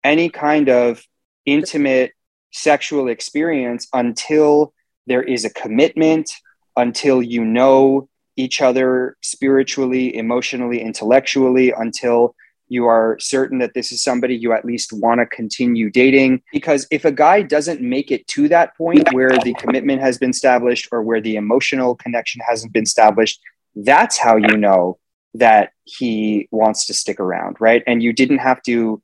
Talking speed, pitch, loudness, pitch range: 155 wpm, 125 Hz, -16 LUFS, 115-135 Hz